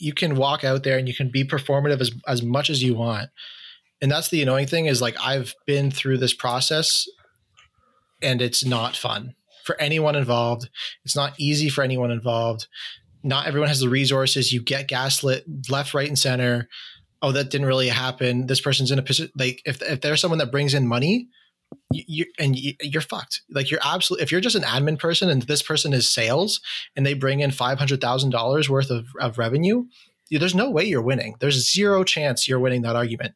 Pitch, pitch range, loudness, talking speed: 135 Hz, 125-150 Hz, -22 LUFS, 205 wpm